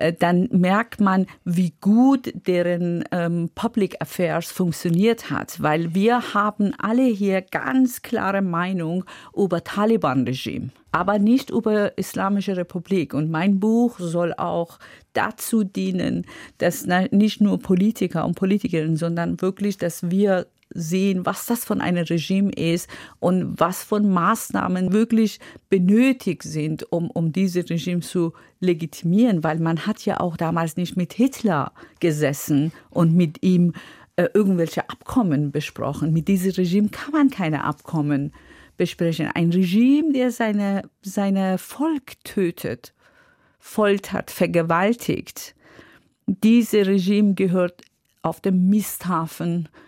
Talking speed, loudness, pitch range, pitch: 125 wpm, -21 LUFS, 170-205 Hz, 185 Hz